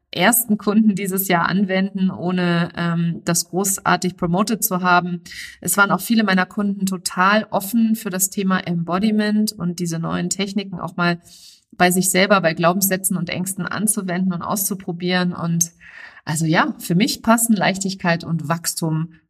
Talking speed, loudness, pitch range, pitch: 150 wpm, -19 LUFS, 175-200 Hz, 185 Hz